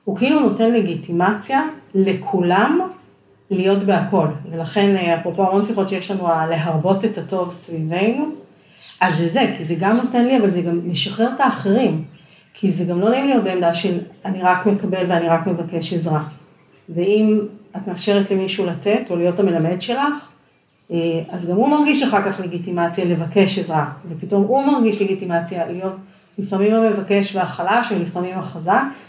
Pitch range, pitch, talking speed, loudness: 175-210 Hz, 190 Hz, 155 wpm, -18 LUFS